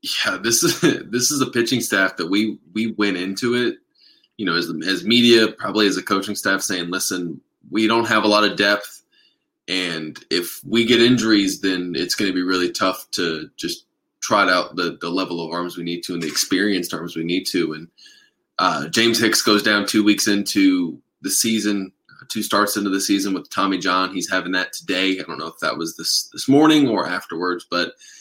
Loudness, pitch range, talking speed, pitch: -19 LUFS, 90-115 Hz, 210 wpm, 100 Hz